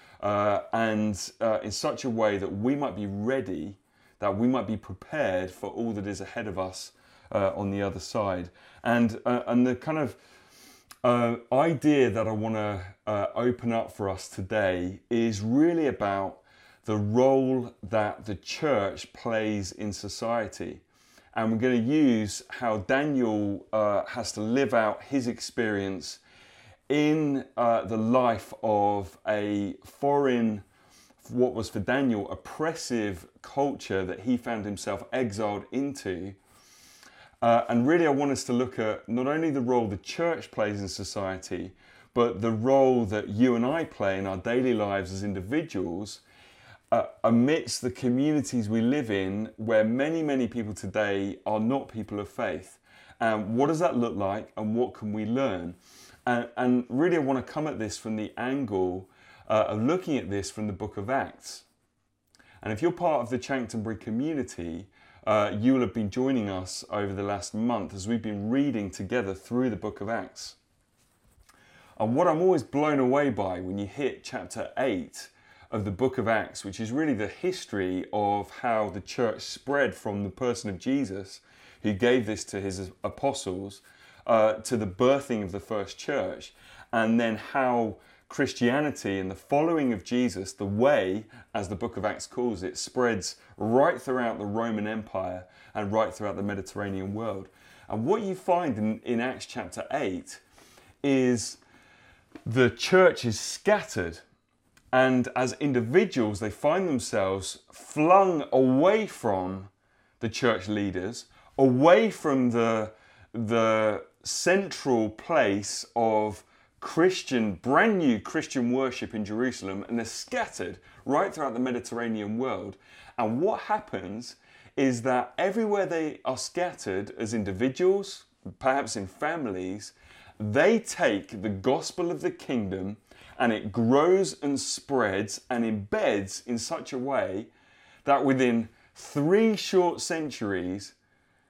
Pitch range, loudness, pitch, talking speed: 100-130 Hz, -28 LUFS, 115 Hz, 155 wpm